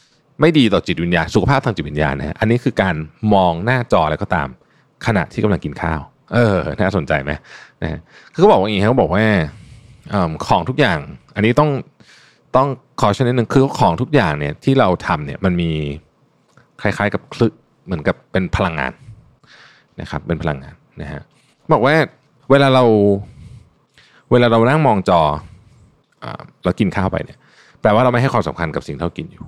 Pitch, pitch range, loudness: 105 Hz, 80-130 Hz, -17 LUFS